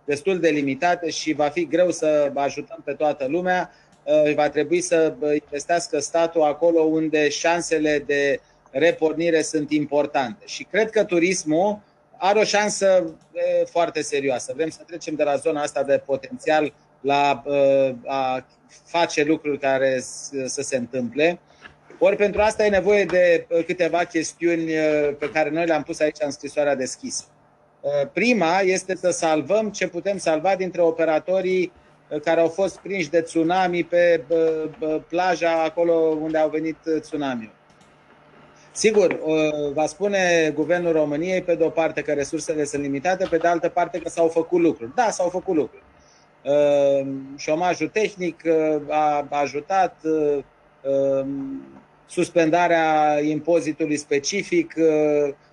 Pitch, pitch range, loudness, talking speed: 160 Hz, 145-175 Hz, -22 LUFS, 130 wpm